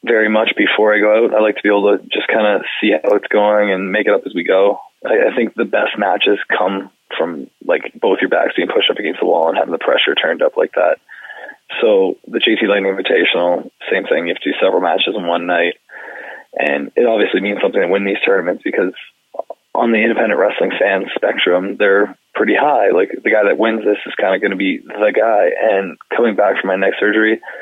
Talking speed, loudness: 225 wpm, -15 LUFS